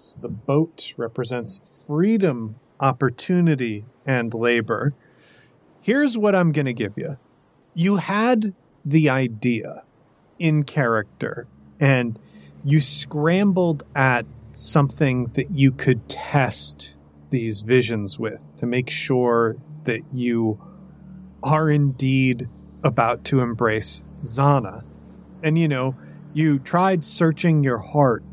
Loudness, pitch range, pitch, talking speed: -21 LUFS, 120-155 Hz, 135 Hz, 110 wpm